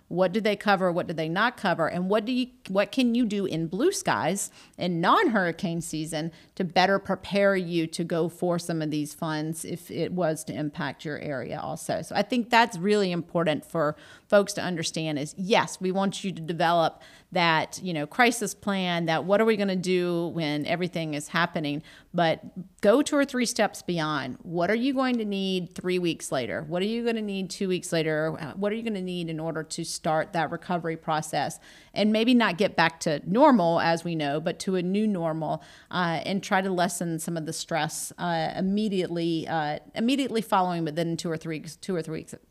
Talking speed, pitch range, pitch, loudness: 215 wpm, 160-200 Hz, 175 Hz, -27 LUFS